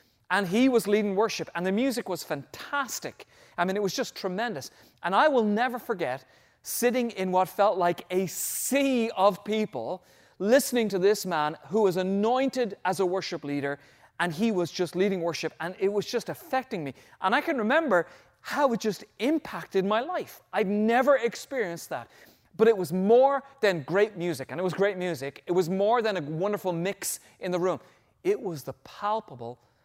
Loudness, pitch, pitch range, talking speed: -27 LUFS, 200 Hz, 180-235 Hz, 185 wpm